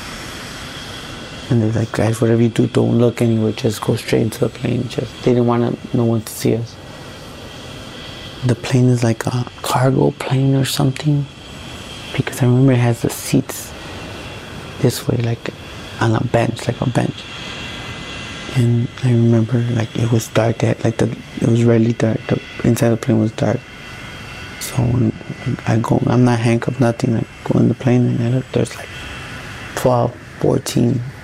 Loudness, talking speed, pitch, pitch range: -17 LUFS, 175 wpm, 120 Hz, 115-125 Hz